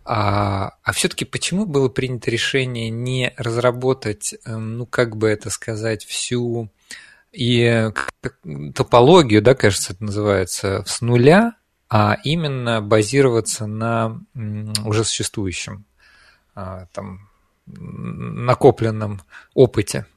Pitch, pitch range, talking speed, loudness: 115 Hz, 105-125 Hz, 95 wpm, -19 LUFS